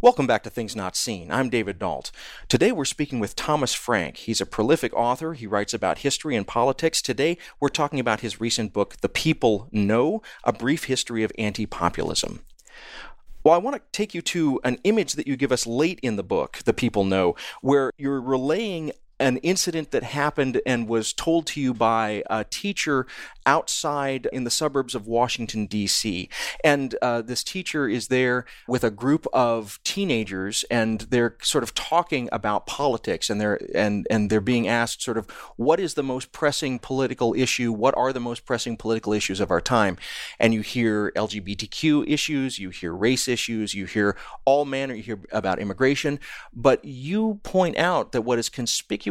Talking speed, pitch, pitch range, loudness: 185 wpm, 125 Hz, 110-140 Hz, -24 LUFS